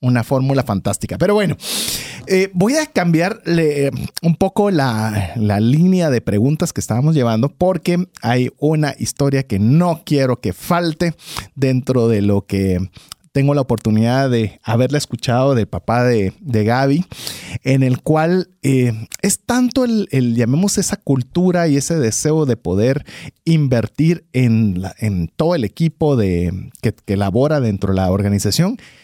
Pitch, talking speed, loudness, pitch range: 135 Hz, 150 wpm, -17 LUFS, 110-165 Hz